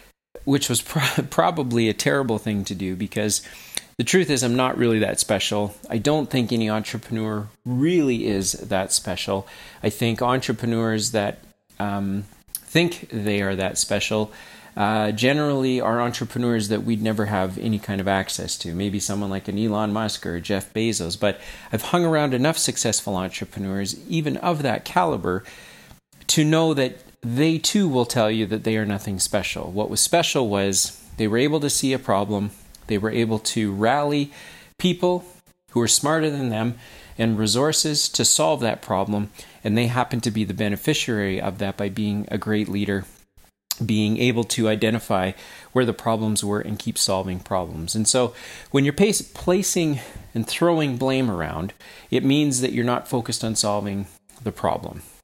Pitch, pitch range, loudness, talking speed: 110 Hz, 100-130 Hz, -22 LUFS, 170 wpm